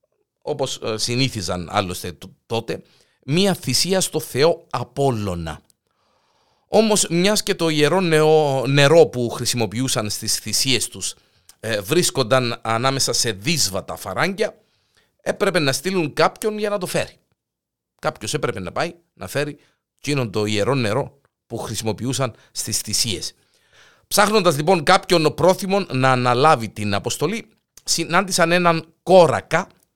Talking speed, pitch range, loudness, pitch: 120 wpm, 115-180 Hz, -19 LUFS, 140 Hz